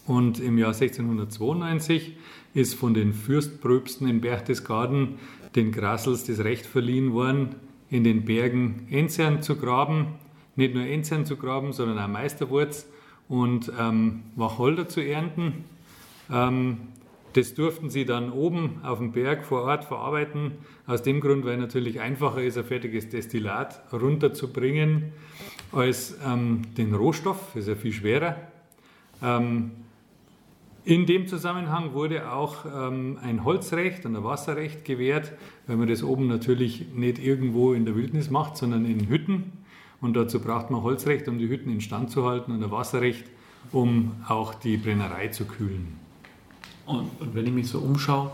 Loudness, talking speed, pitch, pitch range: -26 LUFS, 150 wpm, 130 Hz, 115-145 Hz